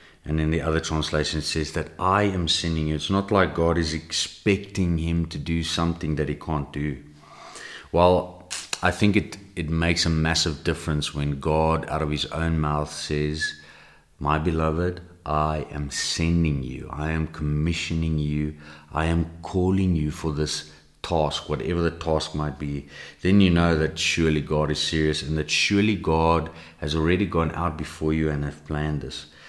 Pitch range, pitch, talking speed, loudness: 75-85 Hz, 80 Hz, 175 wpm, -24 LUFS